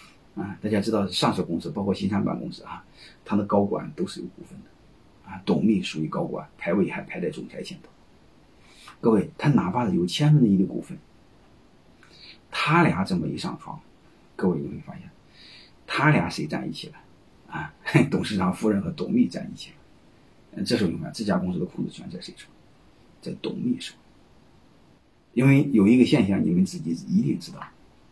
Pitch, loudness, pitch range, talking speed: 110 Hz, -24 LUFS, 100-150 Hz, 265 characters per minute